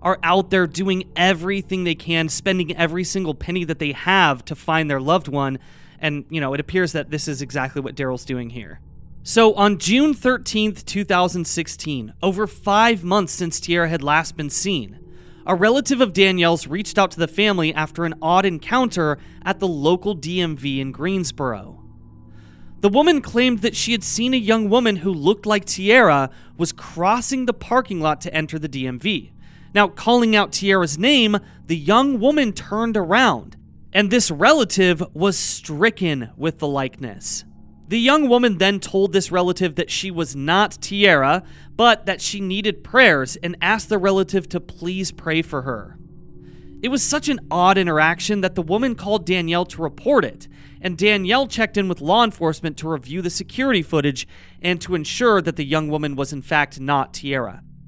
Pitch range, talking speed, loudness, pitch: 155-205 Hz, 175 wpm, -19 LUFS, 180 Hz